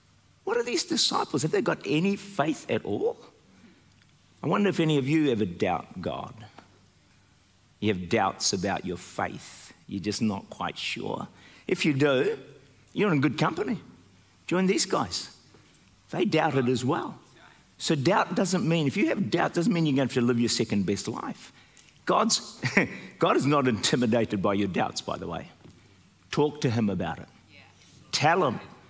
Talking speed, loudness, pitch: 175 wpm, -27 LUFS, 135 Hz